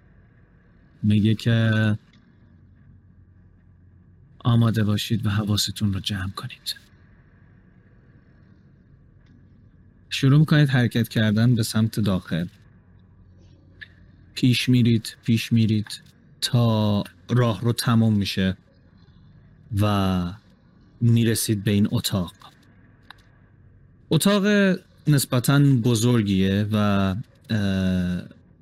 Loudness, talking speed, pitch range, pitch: -22 LUFS, 70 wpm, 95-120 Hz, 110 Hz